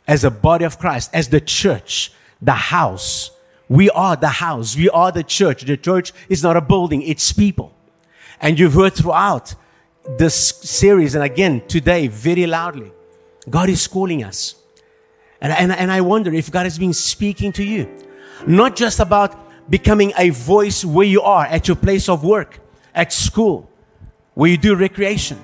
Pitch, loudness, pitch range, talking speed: 180 Hz, -15 LUFS, 155-200 Hz, 170 wpm